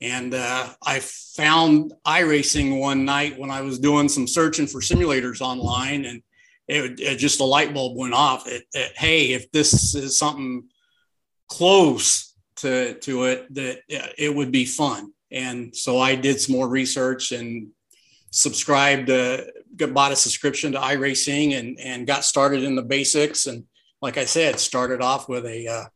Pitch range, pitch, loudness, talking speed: 125-145 Hz, 135 Hz, -21 LUFS, 170 wpm